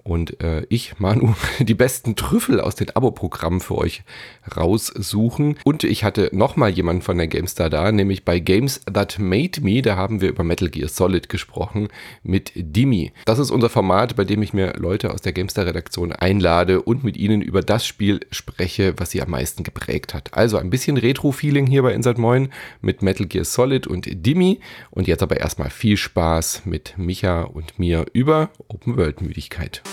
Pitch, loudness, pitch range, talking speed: 100 Hz, -20 LUFS, 90-115 Hz, 180 wpm